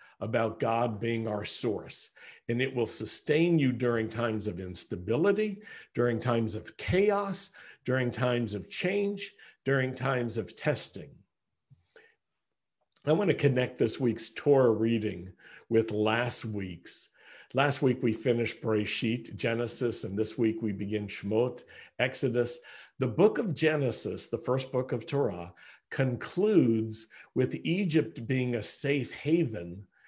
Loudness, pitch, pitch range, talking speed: -30 LUFS, 120 Hz, 110-140 Hz, 130 wpm